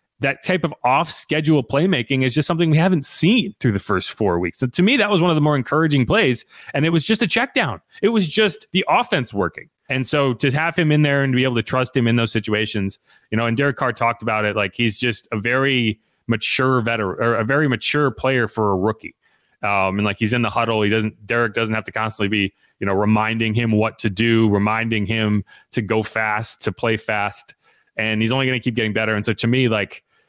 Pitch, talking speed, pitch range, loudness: 115 Hz, 245 wpm, 110-140 Hz, -19 LUFS